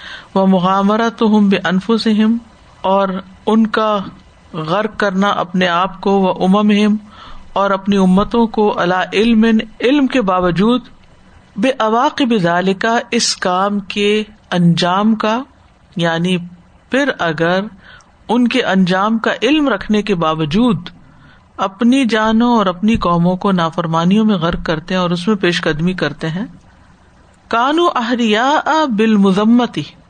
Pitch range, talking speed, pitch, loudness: 185-225 Hz, 135 wpm, 205 Hz, -14 LUFS